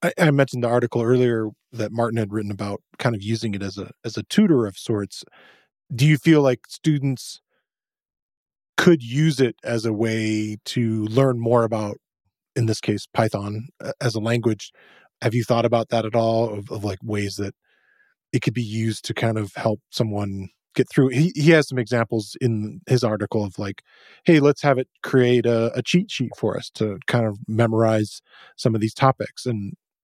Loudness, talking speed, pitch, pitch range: -22 LUFS, 190 wpm, 115 Hz, 110-130 Hz